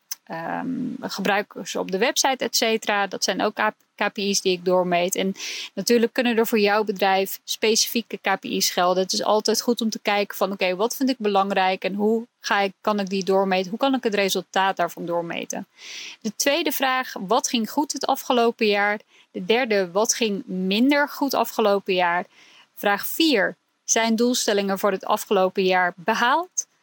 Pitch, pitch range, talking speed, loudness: 215 Hz, 195-245 Hz, 180 wpm, -22 LUFS